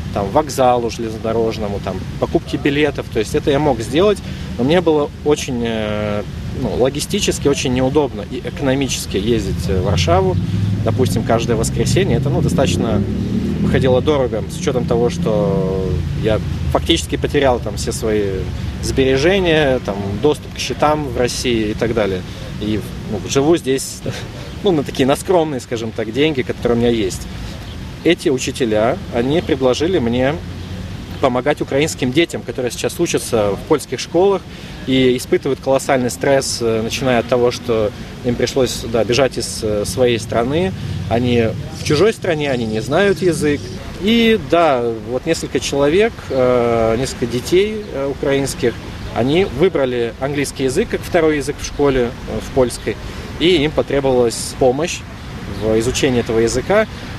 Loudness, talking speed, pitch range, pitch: -17 LUFS, 140 wpm, 110-145 Hz, 125 Hz